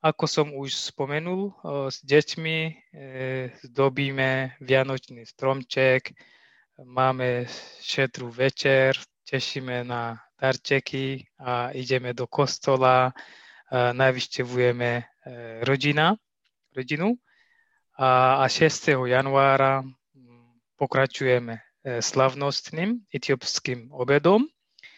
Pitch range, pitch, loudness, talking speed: 125-140 Hz, 135 Hz, -24 LUFS, 80 wpm